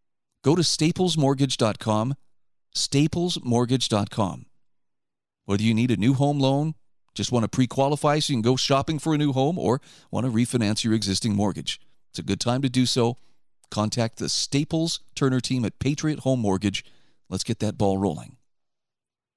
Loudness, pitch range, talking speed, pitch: -24 LUFS, 110-140 Hz, 165 wpm, 125 Hz